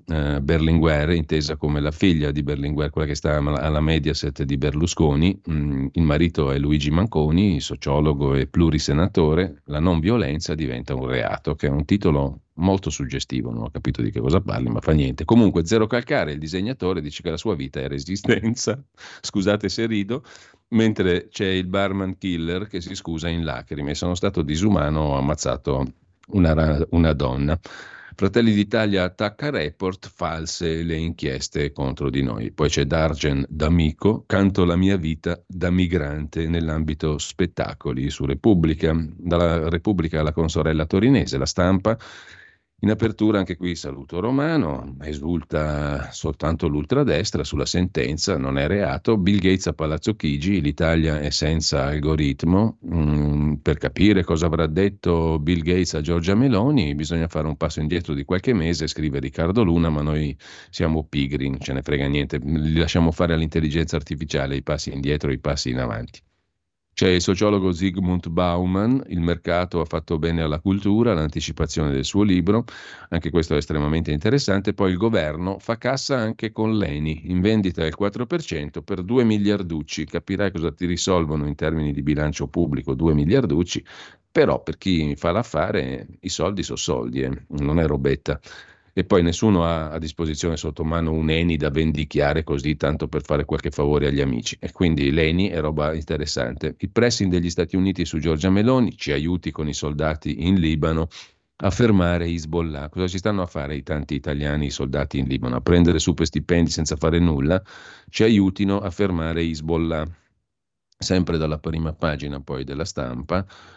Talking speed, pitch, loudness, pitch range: 165 wpm, 80 Hz, -22 LUFS, 75-95 Hz